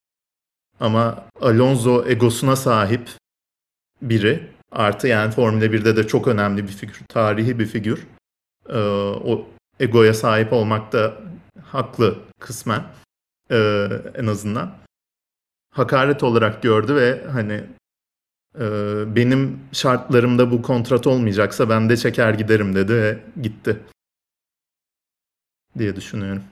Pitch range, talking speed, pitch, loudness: 105-125 Hz, 105 wpm, 110 Hz, -19 LUFS